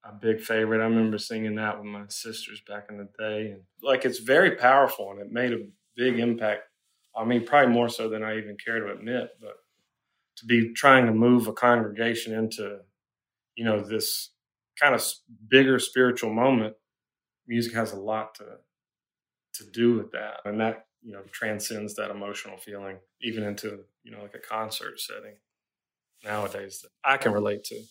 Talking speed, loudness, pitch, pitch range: 180 wpm, -25 LUFS, 110 Hz, 105-120 Hz